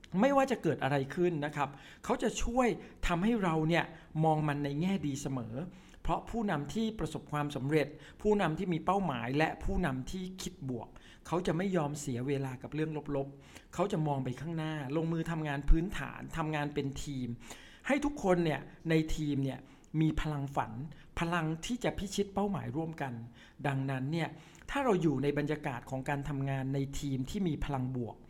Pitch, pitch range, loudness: 155 Hz, 140-175 Hz, -34 LUFS